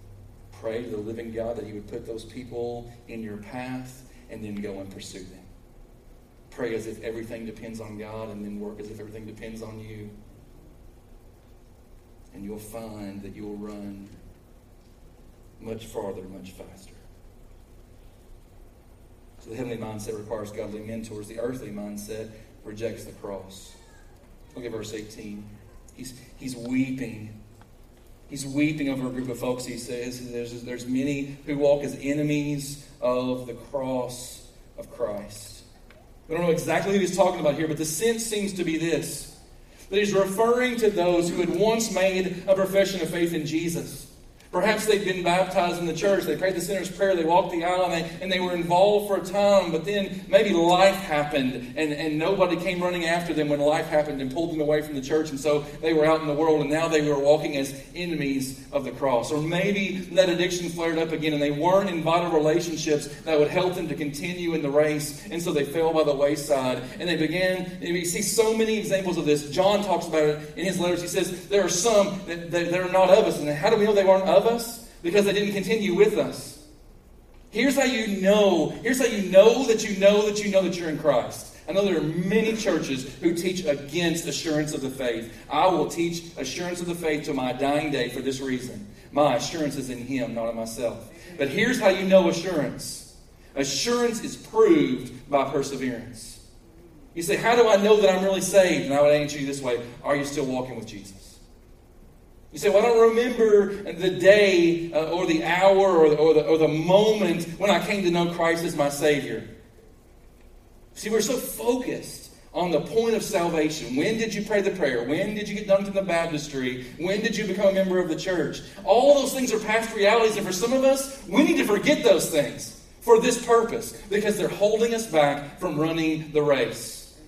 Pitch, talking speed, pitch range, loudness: 155 Hz, 205 wpm, 120-190 Hz, -24 LUFS